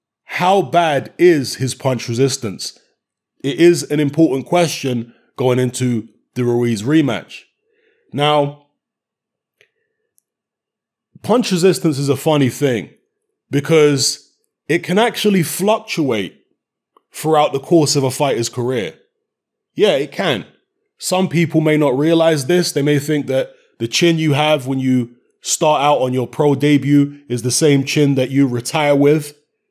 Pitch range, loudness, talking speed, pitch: 130-175 Hz, -16 LUFS, 135 wpm, 150 Hz